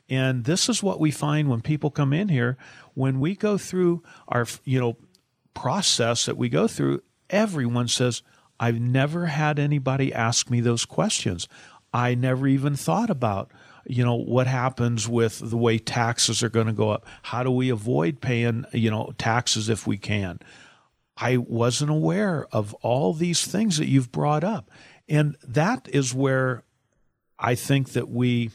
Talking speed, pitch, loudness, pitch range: 170 wpm, 130 Hz, -24 LUFS, 120-150 Hz